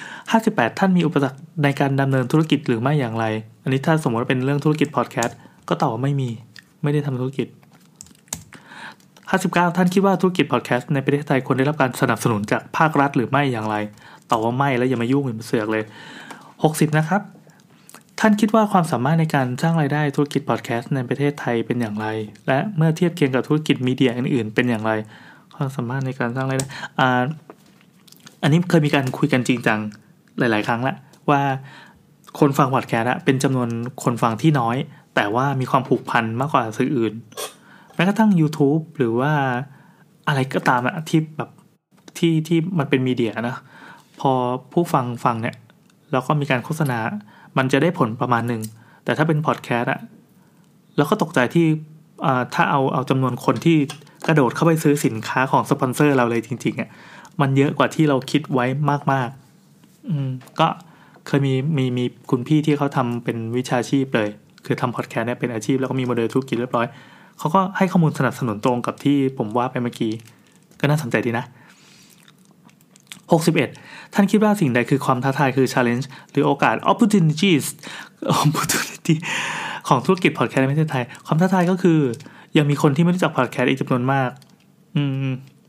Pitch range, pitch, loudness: 125-160 Hz, 140 Hz, -20 LUFS